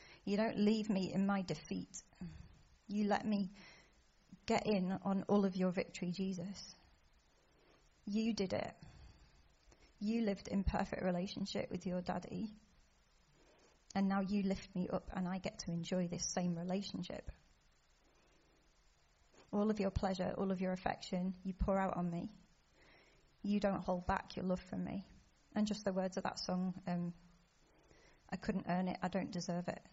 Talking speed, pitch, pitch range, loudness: 160 wpm, 190 Hz, 175-200 Hz, -40 LUFS